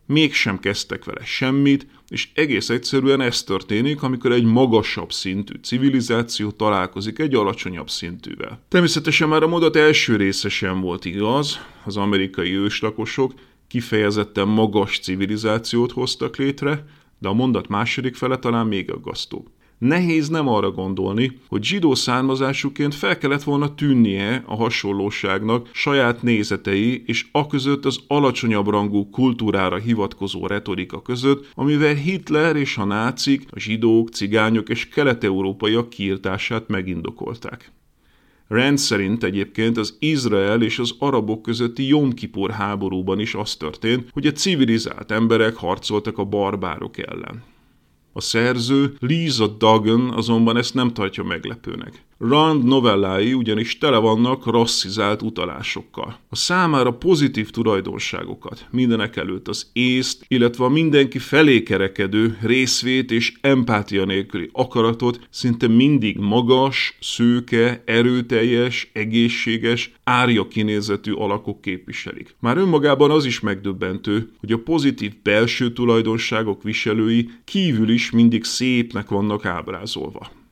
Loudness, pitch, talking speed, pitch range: -19 LUFS, 115 Hz, 120 wpm, 105-130 Hz